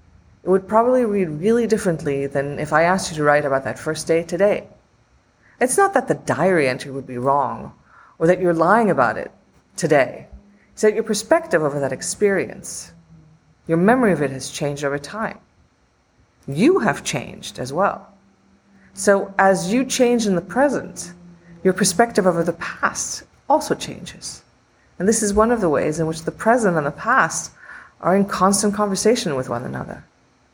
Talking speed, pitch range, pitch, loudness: 175 wpm, 145-210 Hz, 175 Hz, -19 LUFS